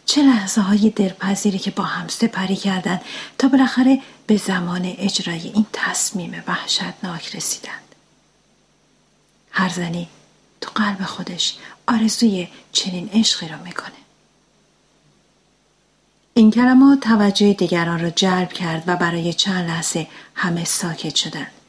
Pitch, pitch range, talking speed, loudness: 195 Hz, 175-220 Hz, 115 wpm, -19 LUFS